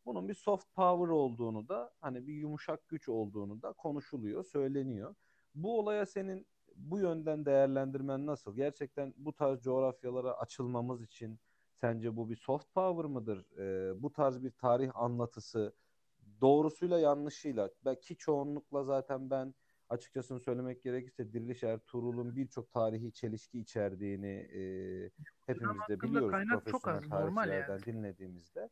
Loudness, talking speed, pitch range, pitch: -37 LUFS, 130 wpm, 115-150 Hz, 130 Hz